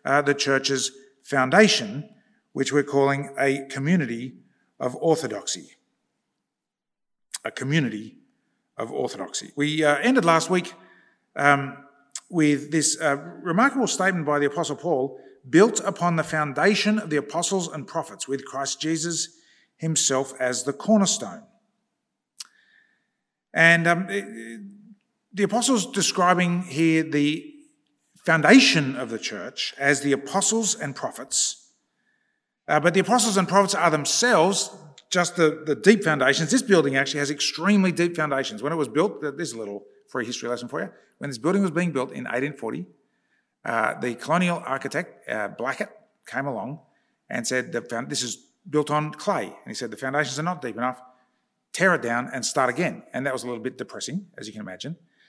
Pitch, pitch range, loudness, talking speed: 160 Hz, 140-195 Hz, -23 LUFS, 160 wpm